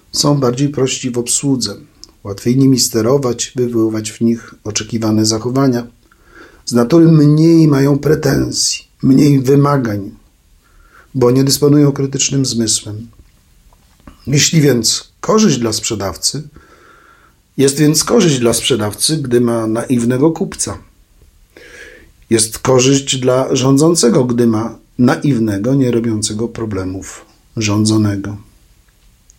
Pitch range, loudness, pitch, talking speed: 110-140 Hz, -13 LUFS, 120 Hz, 100 wpm